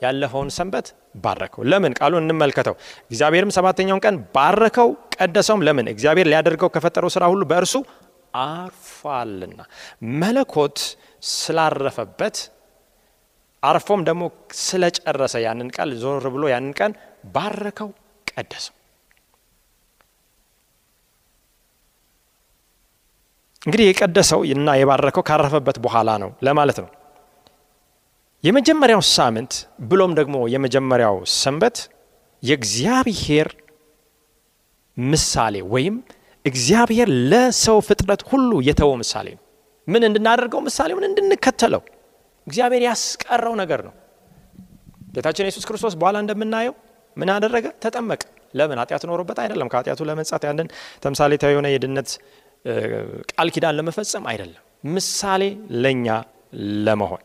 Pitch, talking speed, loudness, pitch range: 170 Hz, 95 wpm, -19 LUFS, 140-210 Hz